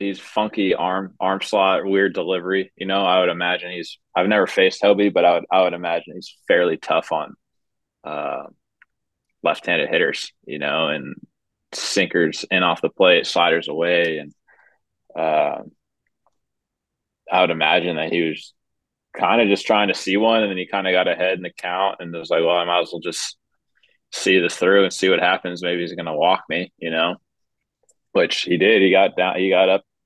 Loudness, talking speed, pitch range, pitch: -19 LUFS, 195 wpm, 85-95 Hz, 95 Hz